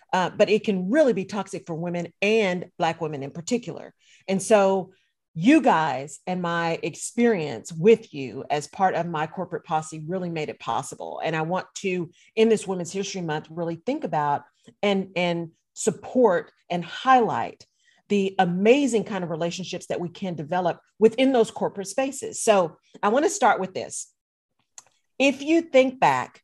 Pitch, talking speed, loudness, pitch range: 185 Hz, 170 wpm, -24 LUFS, 165-220 Hz